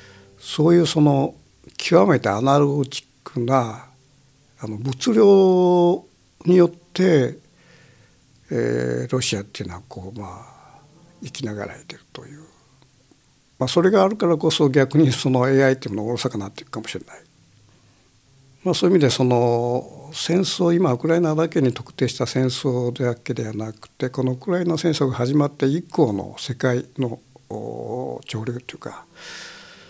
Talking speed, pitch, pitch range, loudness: 295 characters per minute, 130 Hz, 120-160 Hz, -20 LUFS